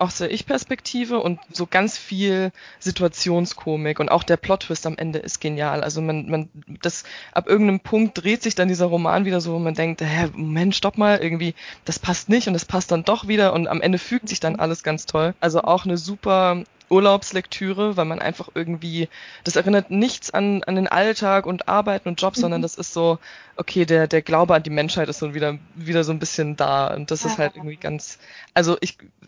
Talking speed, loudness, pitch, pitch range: 210 wpm, -21 LUFS, 175 Hz, 160-195 Hz